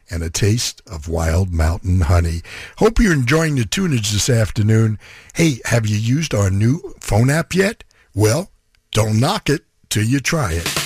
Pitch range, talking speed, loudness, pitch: 95-140 Hz, 170 wpm, -18 LUFS, 110 Hz